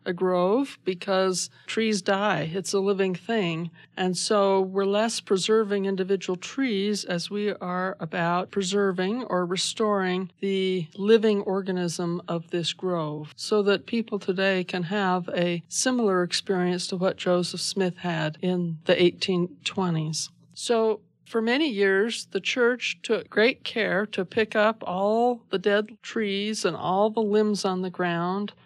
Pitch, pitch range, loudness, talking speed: 195 Hz, 180-210 Hz, -25 LUFS, 145 wpm